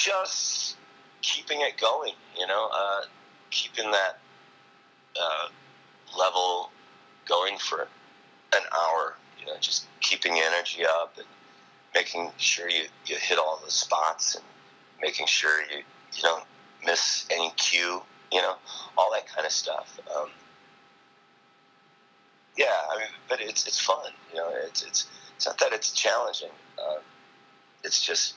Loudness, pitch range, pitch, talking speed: -27 LUFS, 95-100 Hz, 100 Hz, 140 wpm